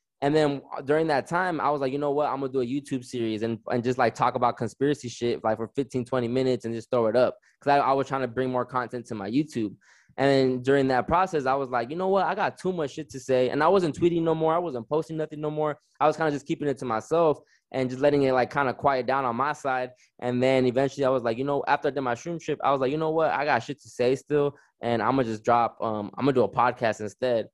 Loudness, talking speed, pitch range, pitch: -26 LUFS, 295 wpm, 125-150 Hz, 135 Hz